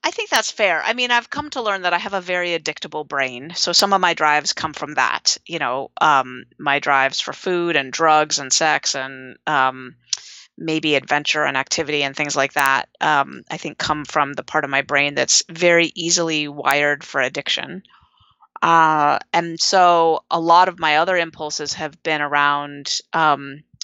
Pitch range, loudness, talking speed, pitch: 140-170 Hz, -18 LUFS, 190 wpm, 155 Hz